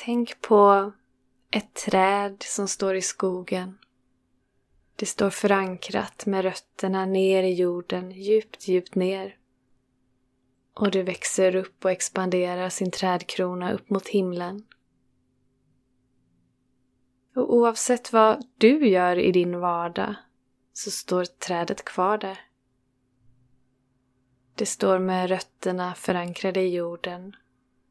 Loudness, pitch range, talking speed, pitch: -24 LUFS, 130-195 Hz, 105 wpm, 185 Hz